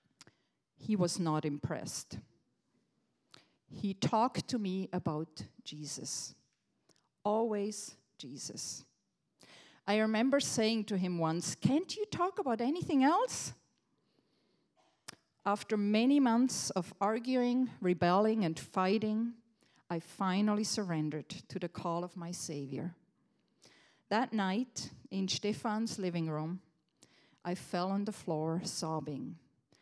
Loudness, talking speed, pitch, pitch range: -34 LUFS, 105 wpm, 195 Hz, 170-220 Hz